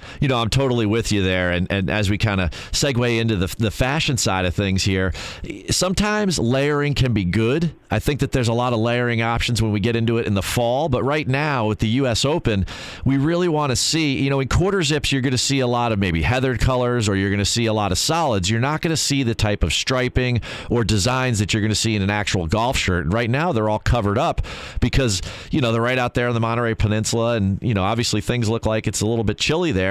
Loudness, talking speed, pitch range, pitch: -20 LUFS, 265 wpm, 105-130 Hz, 115 Hz